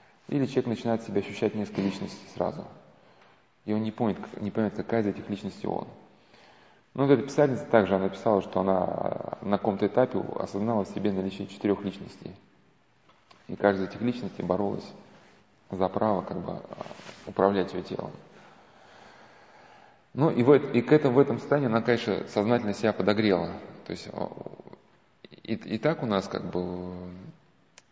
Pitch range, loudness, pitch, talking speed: 95-120 Hz, -28 LUFS, 105 Hz, 155 wpm